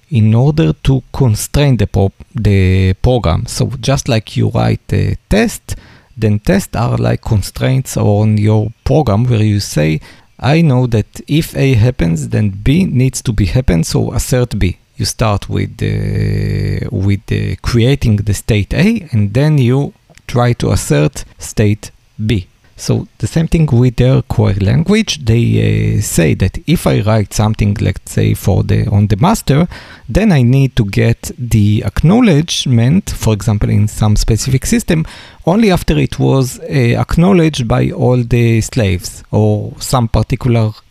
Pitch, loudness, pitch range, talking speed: 115 Hz, -13 LUFS, 105-135 Hz, 160 wpm